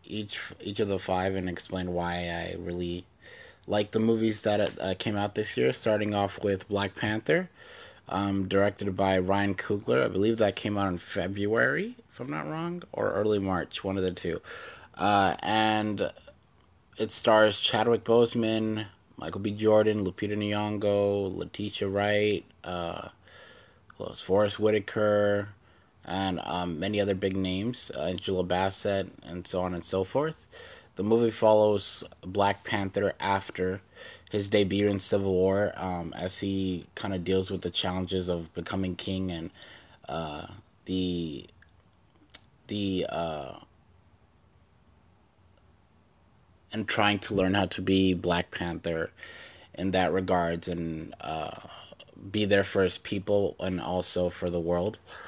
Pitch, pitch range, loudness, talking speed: 95 Hz, 90-105 Hz, -29 LUFS, 140 wpm